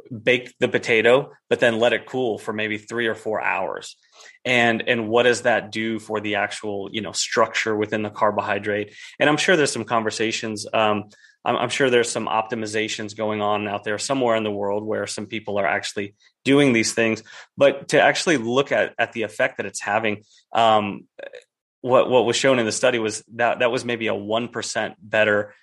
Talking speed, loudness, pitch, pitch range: 210 wpm, -21 LUFS, 110 Hz, 105-120 Hz